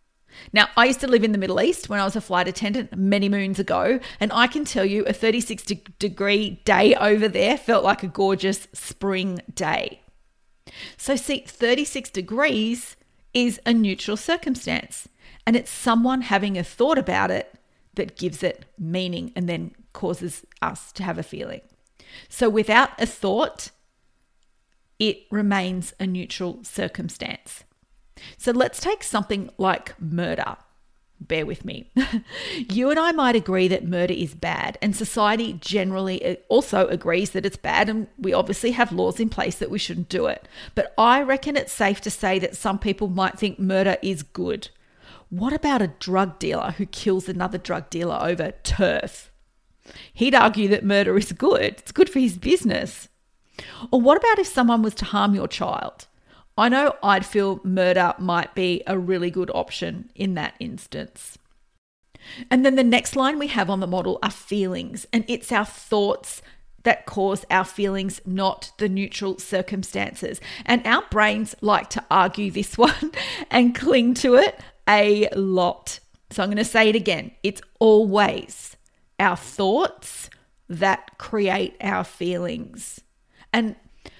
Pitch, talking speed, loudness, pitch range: 205 Hz, 160 wpm, -22 LUFS, 190-235 Hz